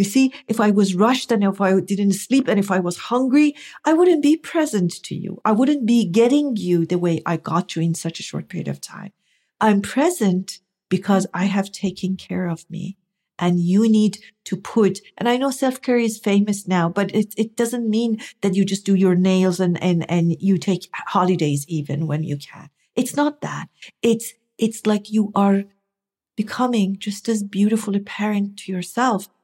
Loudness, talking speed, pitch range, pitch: -20 LUFS, 200 wpm, 185-225 Hz, 200 Hz